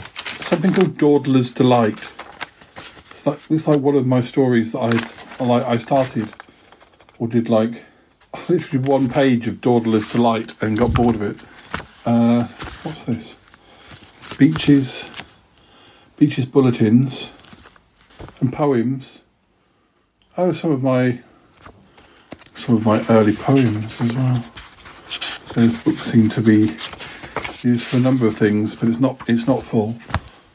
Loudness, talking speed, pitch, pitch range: -18 LUFS, 130 wpm, 120 Hz, 115-135 Hz